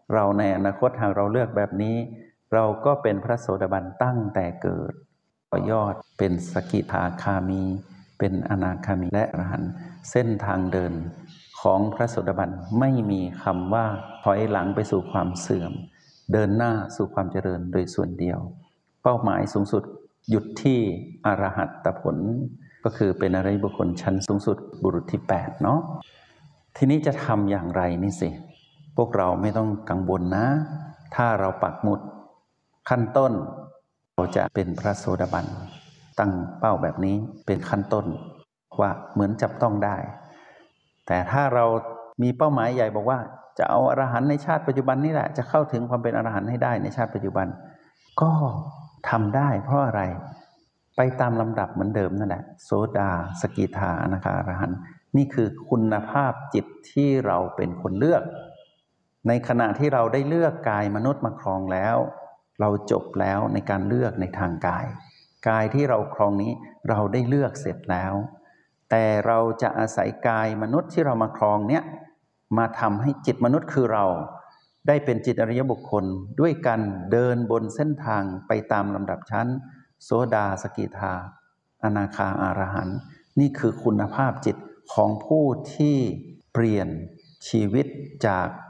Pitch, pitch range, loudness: 110 Hz, 100-130 Hz, -24 LUFS